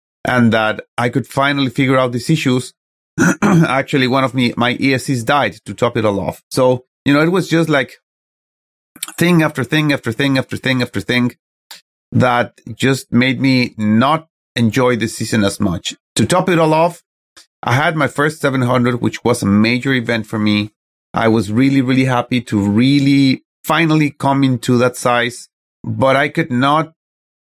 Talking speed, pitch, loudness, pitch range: 175 wpm, 130 Hz, -15 LUFS, 115-140 Hz